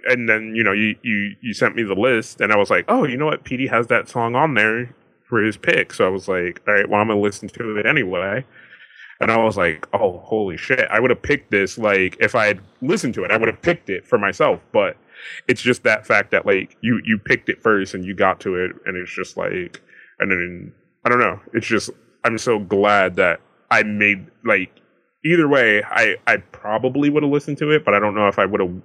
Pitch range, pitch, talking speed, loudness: 100-120 Hz, 110 Hz, 250 wpm, -18 LUFS